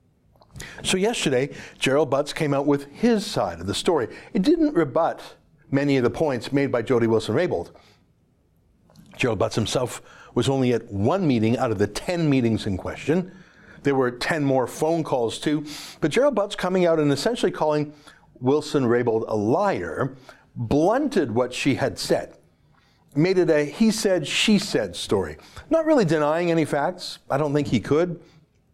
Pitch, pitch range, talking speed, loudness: 150 Hz, 125-165 Hz, 165 wpm, -23 LUFS